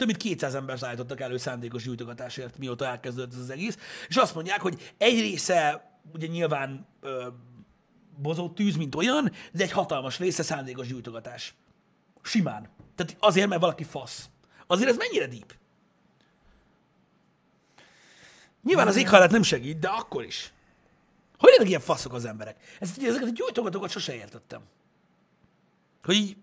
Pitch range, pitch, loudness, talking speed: 125-195 Hz, 155 Hz, -26 LUFS, 150 wpm